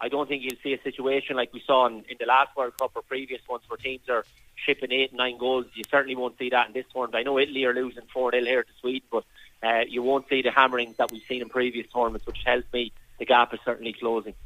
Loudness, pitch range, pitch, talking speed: -26 LUFS, 120-130 Hz, 125 Hz, 275 wpm